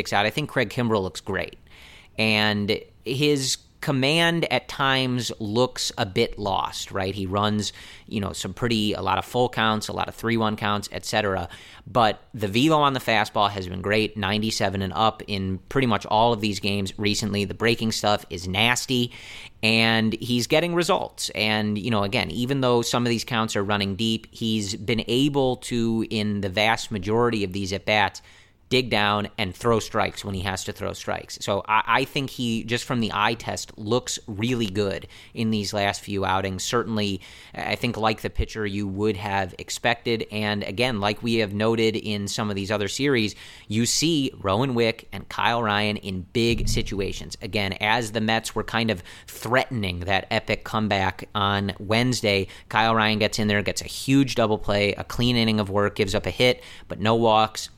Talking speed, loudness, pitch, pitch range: 195 wpm, -24 LUFS, 110 Hz, 100-115 Hz